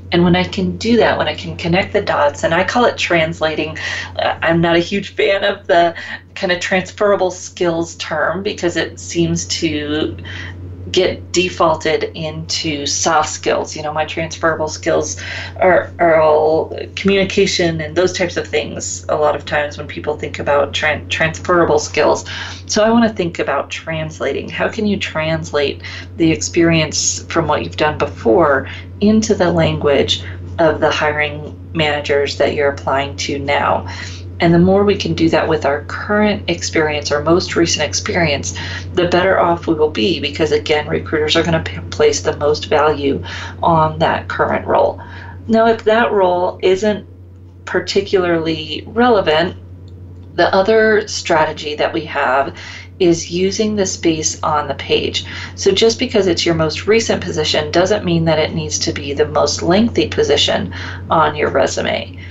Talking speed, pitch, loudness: 165 wpm, 155 Hz, -16 LUFS